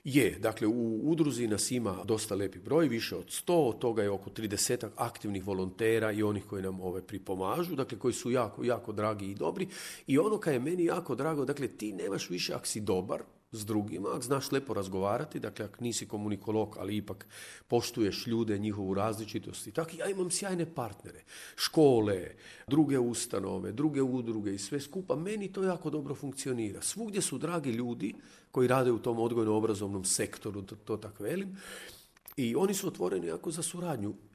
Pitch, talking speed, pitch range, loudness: 115 Hz, 180 wpm, 105-145 Hz, -33 LUFS